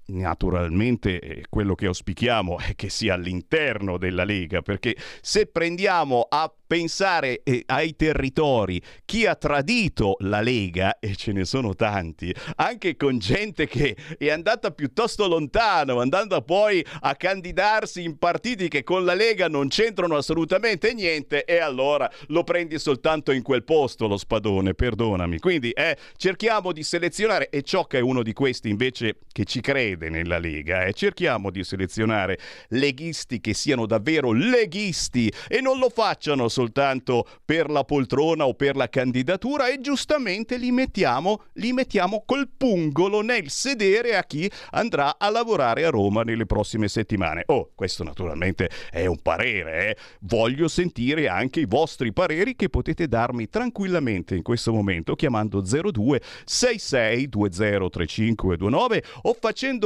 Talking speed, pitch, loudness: 150 wpm, 140 Hz, -23 LUFS